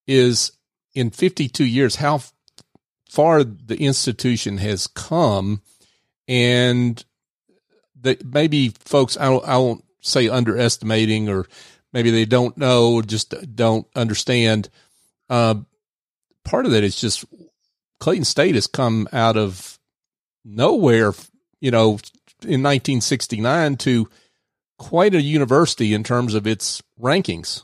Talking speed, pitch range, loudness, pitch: 115 wpm, 110-135 Hz, -19 LUFS, 120 Hz